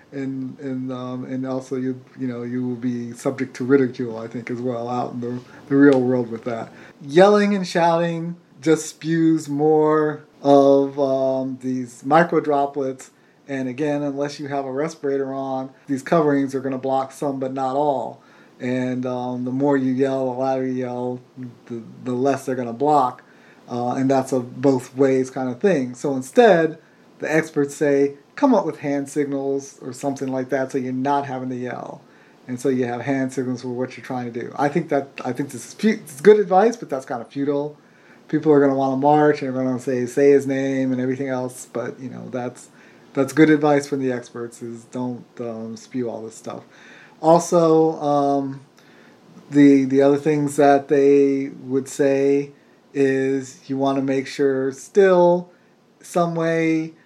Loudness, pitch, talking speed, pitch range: -20 LUFS, 135 Hz, 190 wpm, 130-145 Hz